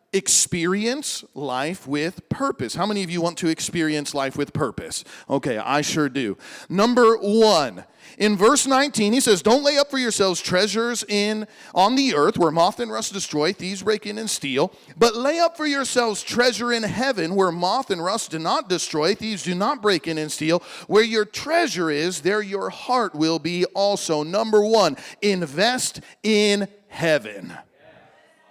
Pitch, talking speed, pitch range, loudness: 205 Hz, 175 wpm, 170-230 Hz, -21 LUFS